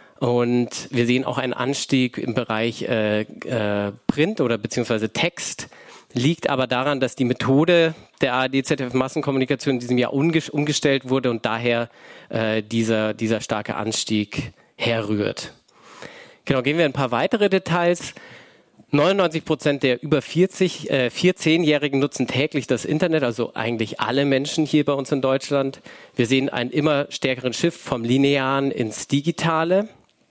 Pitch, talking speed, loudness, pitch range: 135 Hz, 145 wpm, -21 LUFS, 120-150 Hz